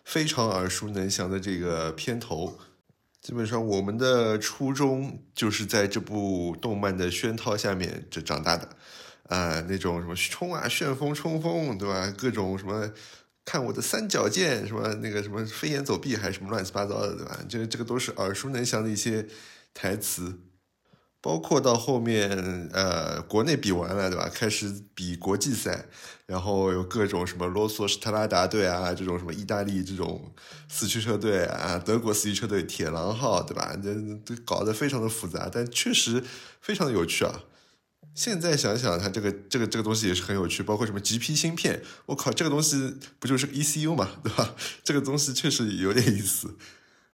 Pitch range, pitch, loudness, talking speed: 95-125 Hz, 105 Hz, -28 LUFS, 280 characters per minute